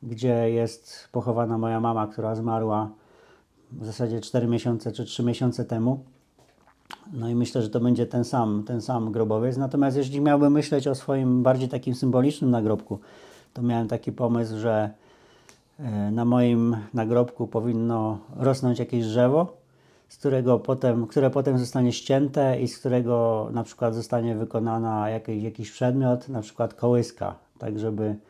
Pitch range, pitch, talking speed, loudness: 115-125 Hz, 120 Hz, 150 wpm, -25 LUFS